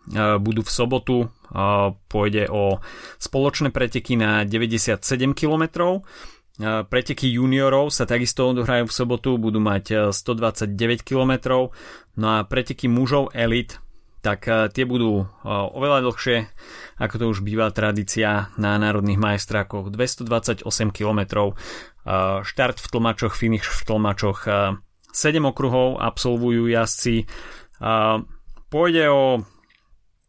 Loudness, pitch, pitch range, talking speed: -21 LUFS, 115 Hz, 105-125 Hz, 105 wpm